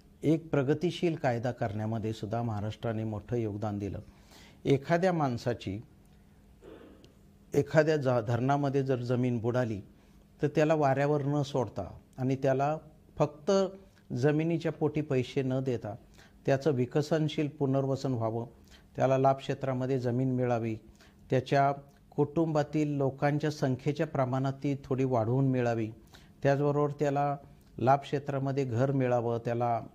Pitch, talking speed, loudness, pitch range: 135 Hz, 105 wpm, -30 LUFS, 120-145 Hz